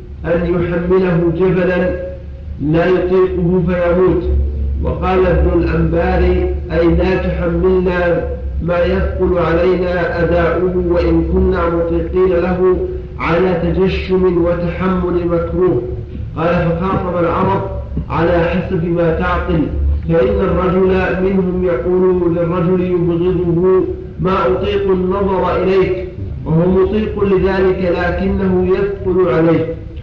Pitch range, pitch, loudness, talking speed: 170-185 Hz, 175 Hz, -15 LUFS, 95 wpm